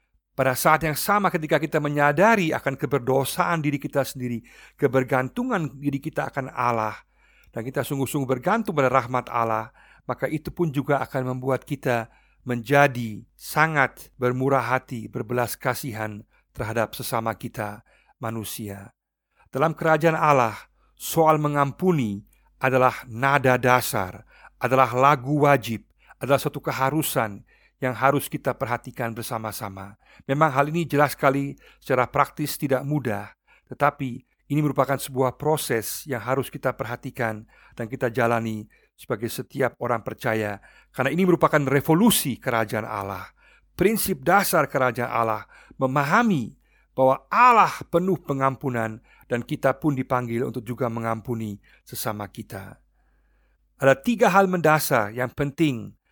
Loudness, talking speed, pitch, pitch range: -23 LUFS, 125 wpm, 130 Hz, 120-150 Hz